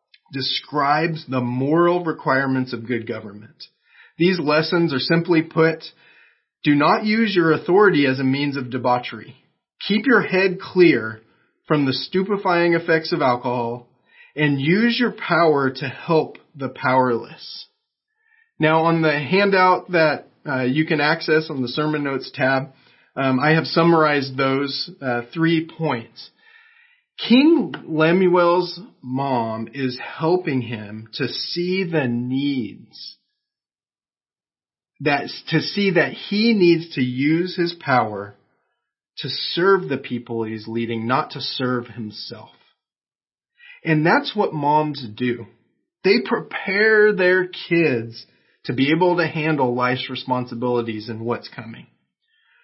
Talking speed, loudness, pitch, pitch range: 125 wpm, -20 LUFS, 150 Hz, 125-175 Hz